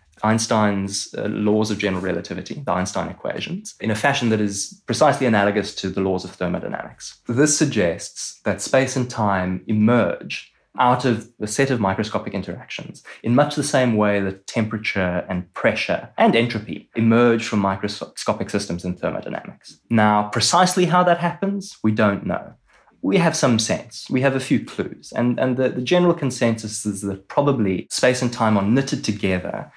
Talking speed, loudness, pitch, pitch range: 170 wpm, -21 LUFS, 110 Hz, 100-130 Hz